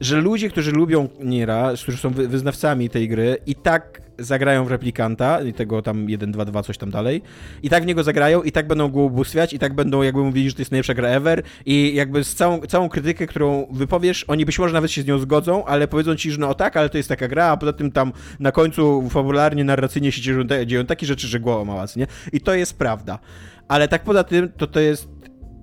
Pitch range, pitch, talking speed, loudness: 125-155 Hz, 140 Hz, 235 wpm, -20 LUFS